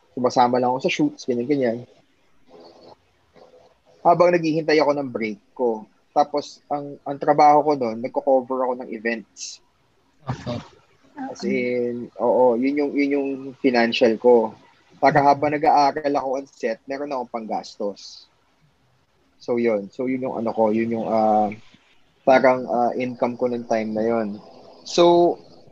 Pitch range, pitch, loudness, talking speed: 115-145 Hz, 125 Hz, -21 LUFS, 140 wpm